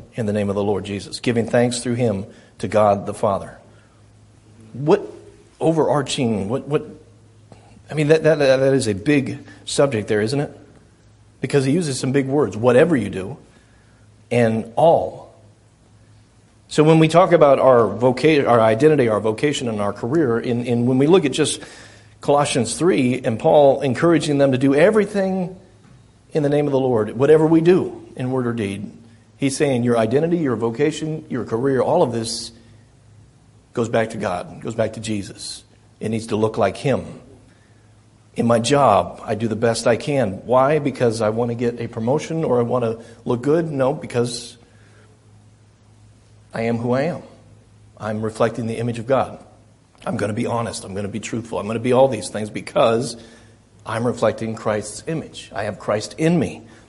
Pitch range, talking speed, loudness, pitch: 110-135 Hz, 185 wpm, -19 LUFS, 115 Hz